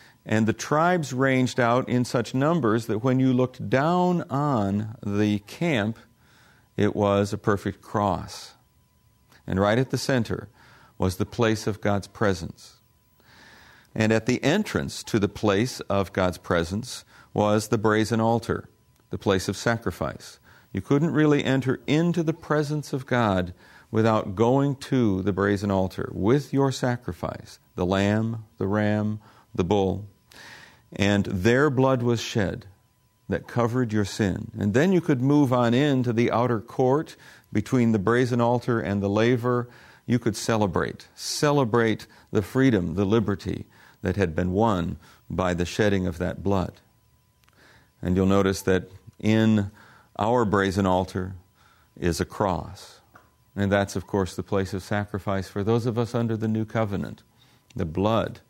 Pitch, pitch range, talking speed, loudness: 110 Hz, 100-125 Hz, 150 wpm, -24 LUFS